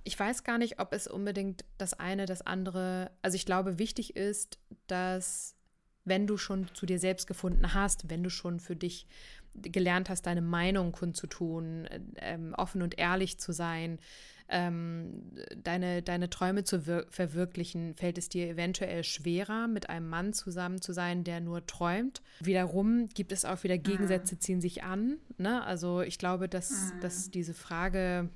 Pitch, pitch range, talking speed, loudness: 185 Hz, 175-195 Hz, 165 wpm, -34 LUFS